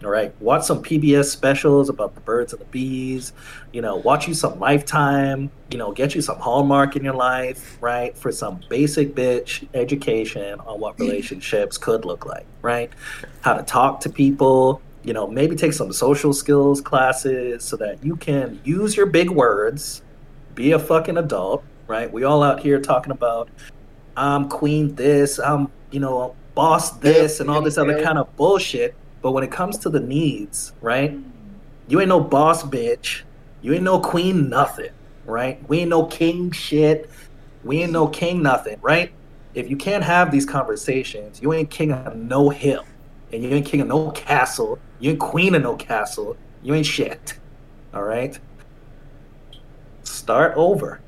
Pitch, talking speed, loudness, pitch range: 140 Hz, 175 wpm, -20 LUFS, 130-155 Hz